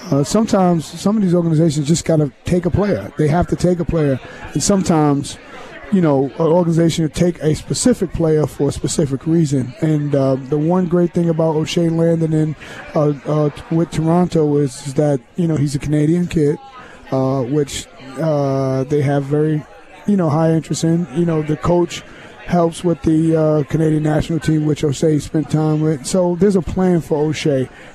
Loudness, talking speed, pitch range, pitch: -17 LUFS, 190 wpm, 150-170 Hz, 155 Hz